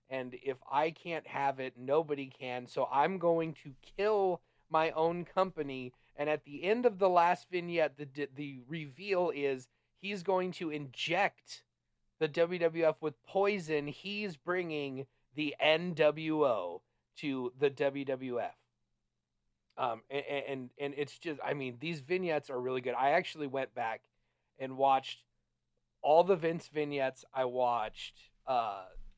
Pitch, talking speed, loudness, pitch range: 145 Hz, 140 wpm, -34 LUFS, 130-165 Hz